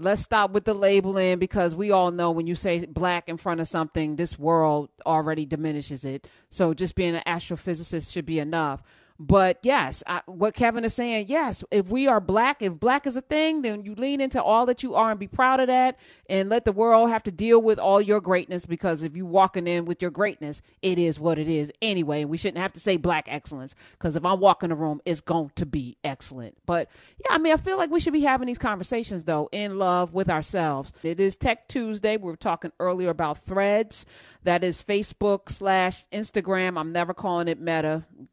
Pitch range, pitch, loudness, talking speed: 165-215 Hz, 185 Hz, -24 LUFS, 220 wpm